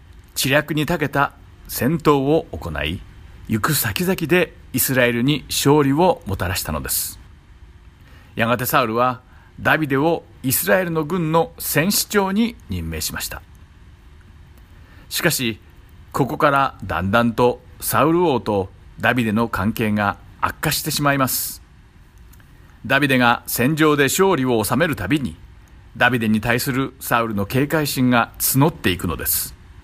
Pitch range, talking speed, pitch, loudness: 90-140 Hz, 270 characters per minute, 115 Hz, -19 LUFS